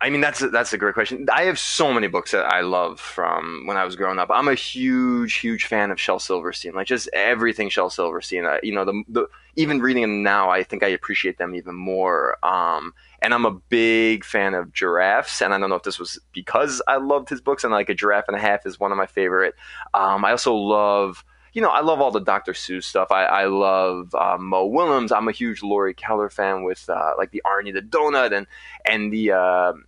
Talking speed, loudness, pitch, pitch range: 240 wpm, -21 LUFS, 100 Hz, 95-115 Hz